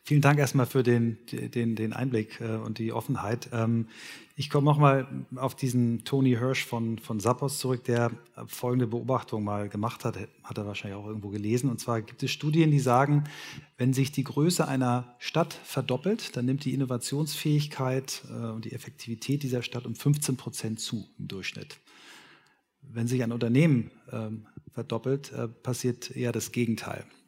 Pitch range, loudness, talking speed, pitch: 115-135 Hz, -29 LUFS, 160 wpm, 125 Hz